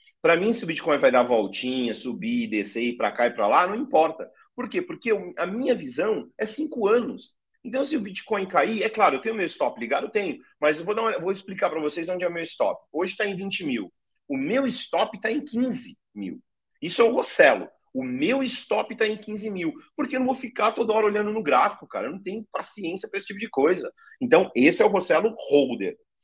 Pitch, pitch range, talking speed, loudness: 225 Hz, 190-270 Hz, 240 wpm, -25 LUFS